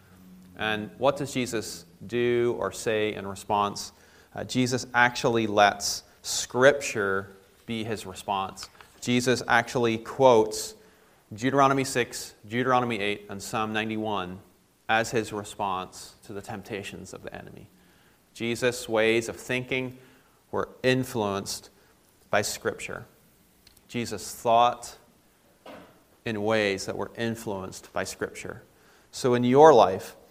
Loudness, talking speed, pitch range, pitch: -26 LUFS, 115 wpm, 100-120 Hz, 110 Hz